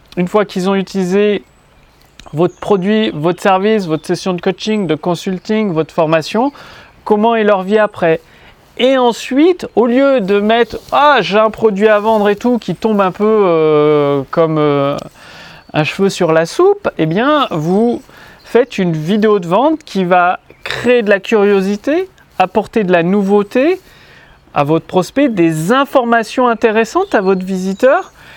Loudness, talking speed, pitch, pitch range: -13 LUFS, 160 wpm, 205 Hz, 180-230 Hz